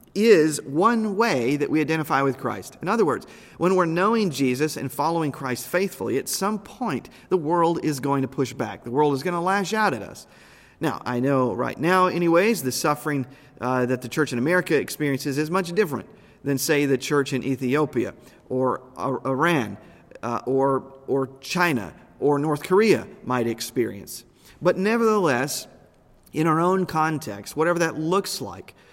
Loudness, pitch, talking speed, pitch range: -23 LUFS, 145 Hz, 175 wpm, 130-175 Hz